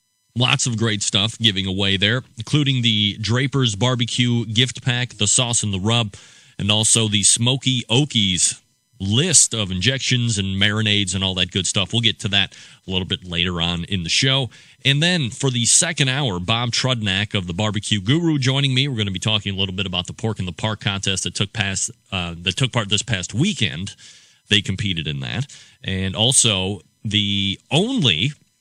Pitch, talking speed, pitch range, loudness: 110 Hz, 190 wpm, 100-125 Hz, -19 LUFS